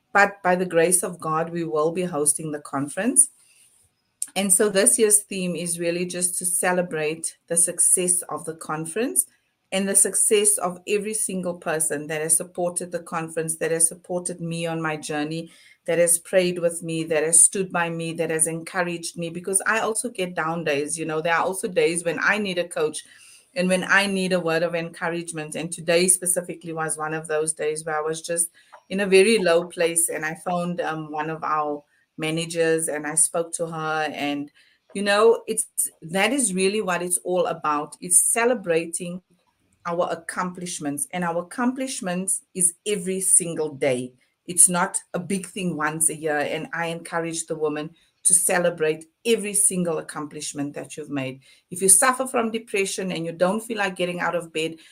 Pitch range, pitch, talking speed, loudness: 160-190 Hz, 175 Hz, 190 wpm, -22 LUFS